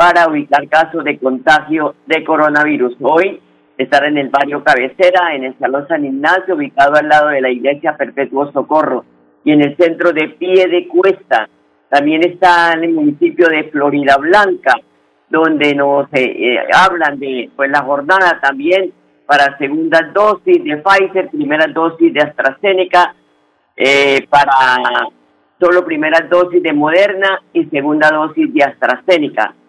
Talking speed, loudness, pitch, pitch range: 145 wpm, -12 LUFS, 150 Hz, 140-175 Hz